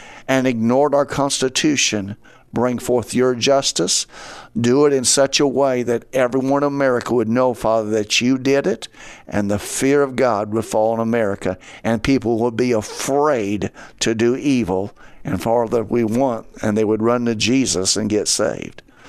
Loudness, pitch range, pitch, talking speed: -18 LUFS, 110-135 Hz, 120 Hz, 175 wpm